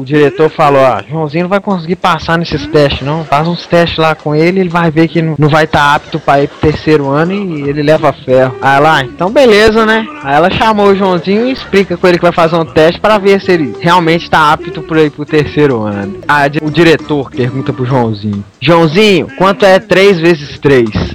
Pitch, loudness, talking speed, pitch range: 160 Hz, -9 LUFS, 220 wpm, 145-180 Hz